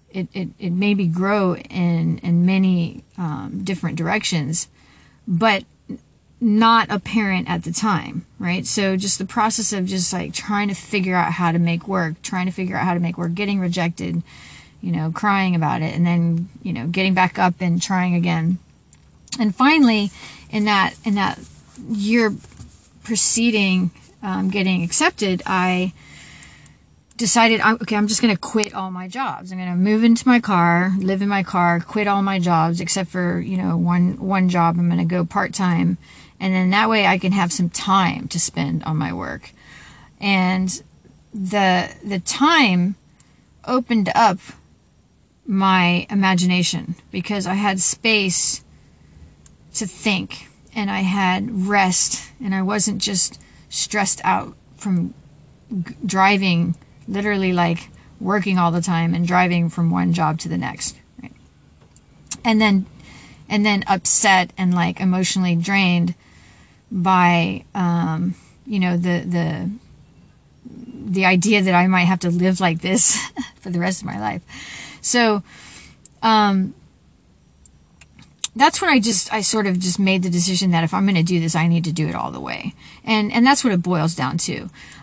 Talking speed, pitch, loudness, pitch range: 160 wpm, 185 Hz, -19 LUFS, 175-205 Hz